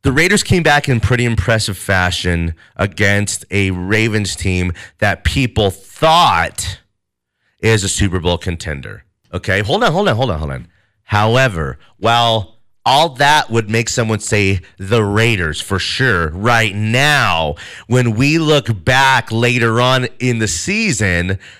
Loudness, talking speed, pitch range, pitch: -14 LUFS, 145 wpm, 95-125 Hz, 110 Hz